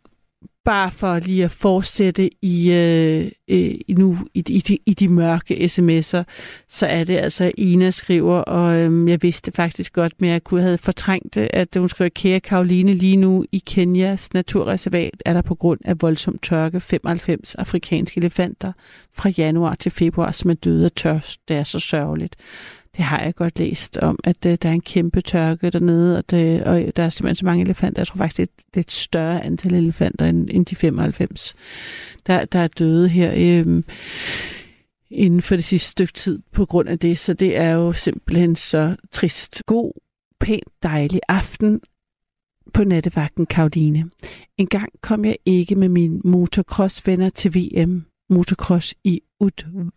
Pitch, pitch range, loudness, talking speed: 175 Hz, 170-185 Hz, -19 LUFS, 170 wpm